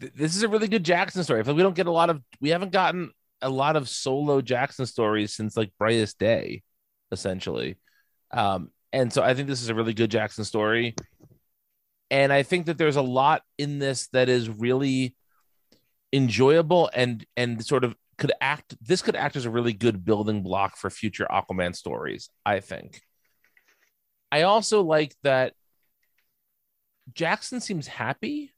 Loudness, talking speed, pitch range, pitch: -25 LUFS, 170 wpm, 115-165 Hz, 130 Hz